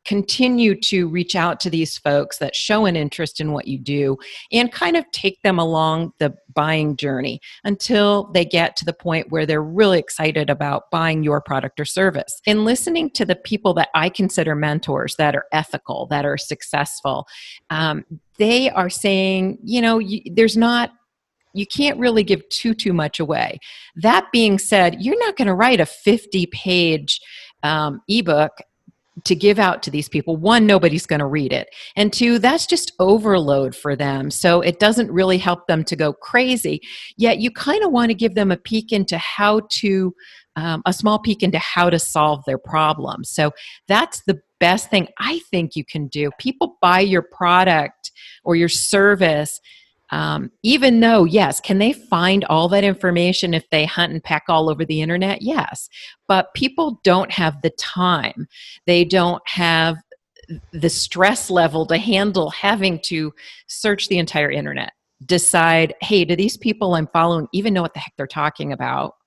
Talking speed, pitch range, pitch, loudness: 180 wpm, 160-210 Hz, 180 Hz, -18 LUFS